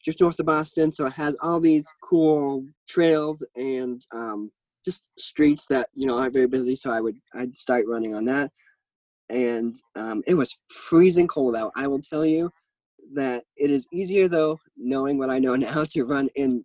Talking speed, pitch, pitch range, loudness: 190 wpm, 140 Hz, 125-155 Hz, -24 LUFS